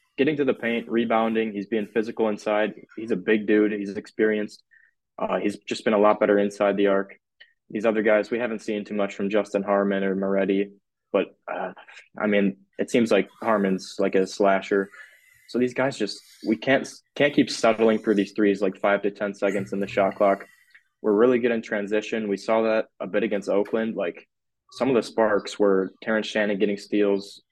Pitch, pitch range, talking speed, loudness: 105 Hz, 100-110 Hz, 200 wpm, -24 LUFS